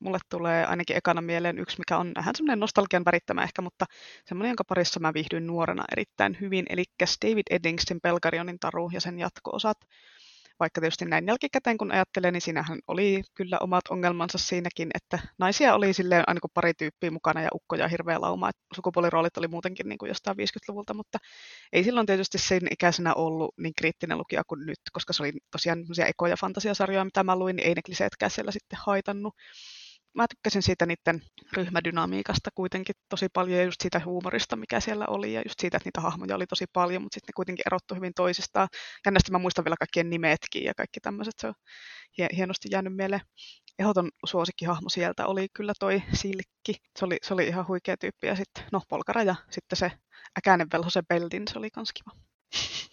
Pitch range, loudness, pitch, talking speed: 170-195 Hz, -28 LUFS, 180 Hz, 185 wpm